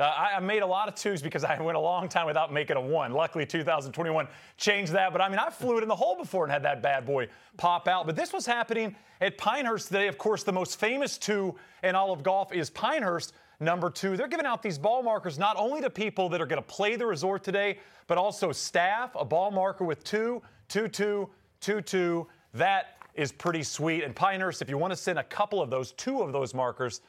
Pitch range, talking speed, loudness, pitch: 165-210 Hz, 240 wpm, -29 LUFS, 190 Hz